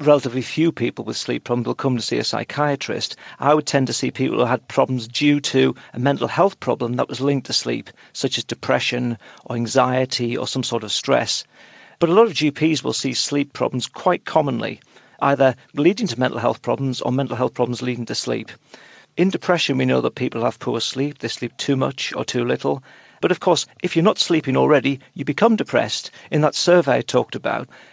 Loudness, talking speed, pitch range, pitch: -20 LUFS, 215 wpm, 120-150 Hz, 135 Hz